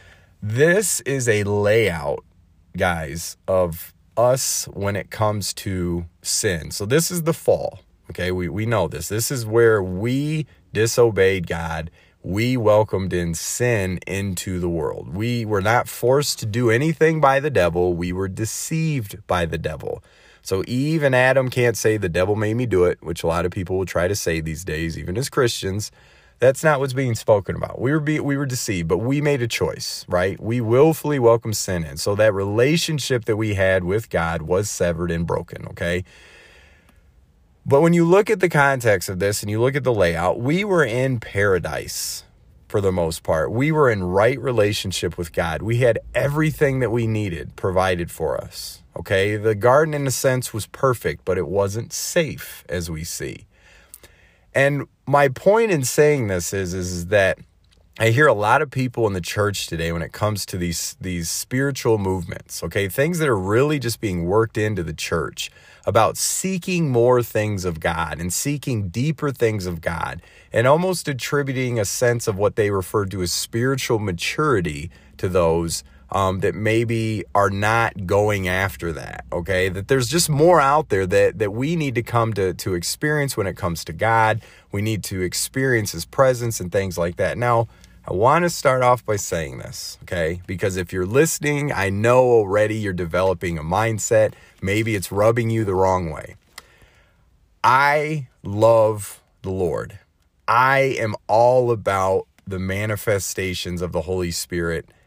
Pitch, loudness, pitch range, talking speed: 105 Hz, -20 LUFS, 90-125 Hz, 180 wpm